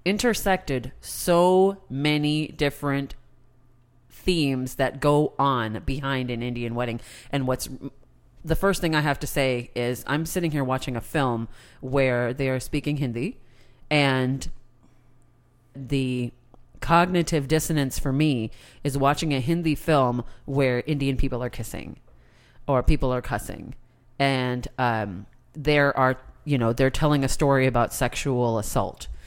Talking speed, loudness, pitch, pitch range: 135 wpm, -24 LUFS, 130 Hz, 120-145 Hz